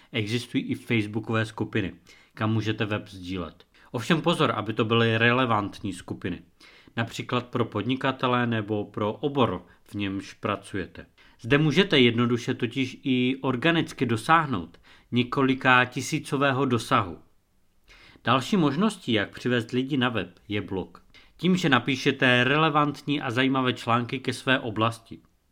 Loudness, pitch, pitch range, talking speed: -25 LUFS, 120 Hz, 105-135 Hz, 125 wpm